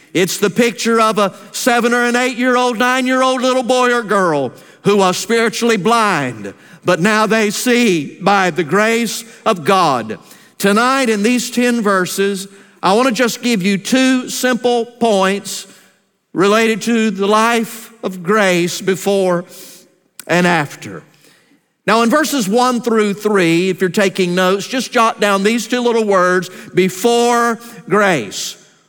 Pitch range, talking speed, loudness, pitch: 190-235 Hz, 150 wpm, -14 LUFS, 215 Hz